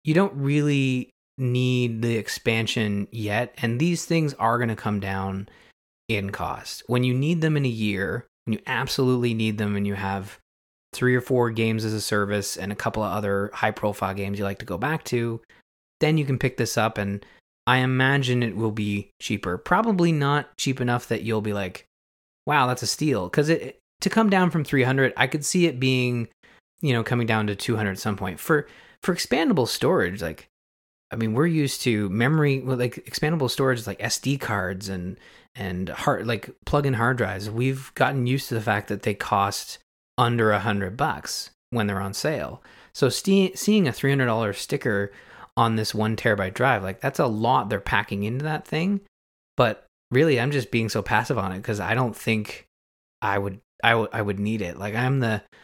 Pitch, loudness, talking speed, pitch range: 115 Hz, -24 LUFS, 200 wpm, 100-130 Hz